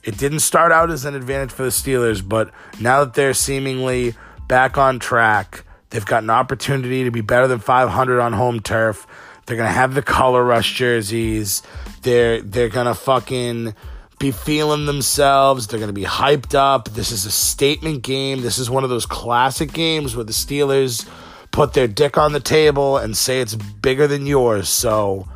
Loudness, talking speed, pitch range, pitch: -17 LUFS, 190 wpm, 115-135 Hz, 125 Hz